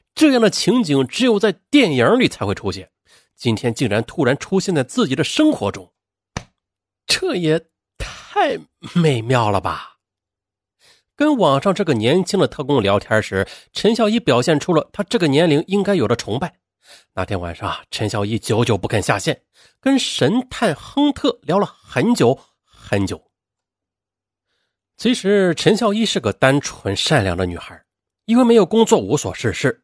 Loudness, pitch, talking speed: -18 LUFS, 155 Hz, 235 characters per minute